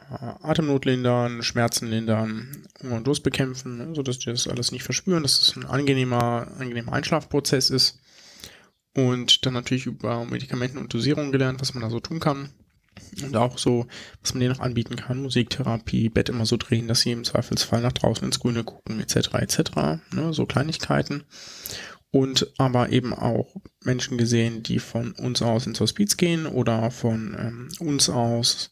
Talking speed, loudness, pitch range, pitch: 170 wpm, -24 LUFS, 115-135 Hz, 125 Hz